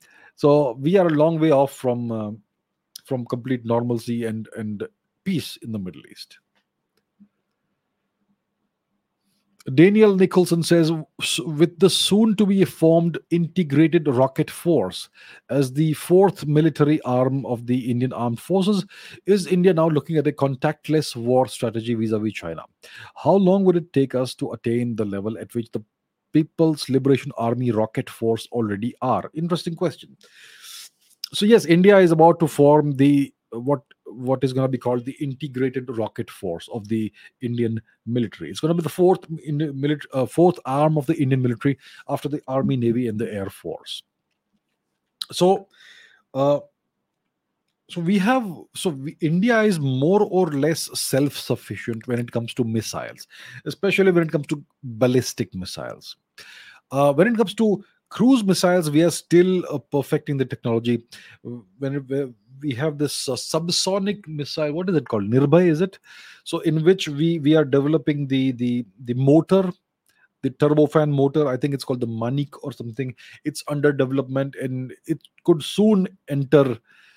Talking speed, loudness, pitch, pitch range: 160 wpm, -21 LUFS, 145 Hz, 125-170 Hz